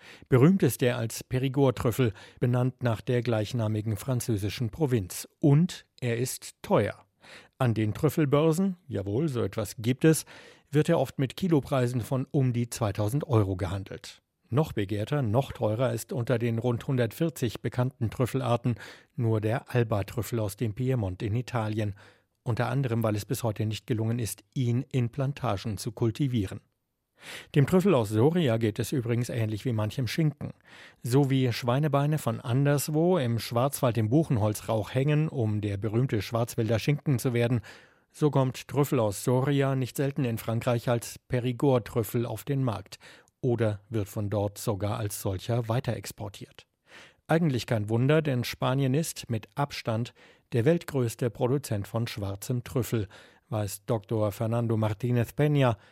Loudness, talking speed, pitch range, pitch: -28 LUFS, 150 wpm, 110-135 Hz, 120 Hz